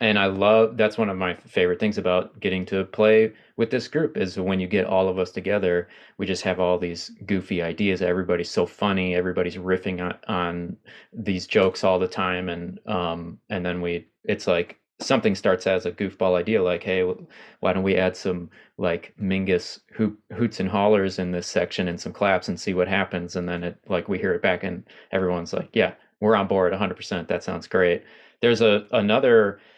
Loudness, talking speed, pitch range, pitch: -24 LUFS, 205 wpm, 90-100 Hz, 95 Hz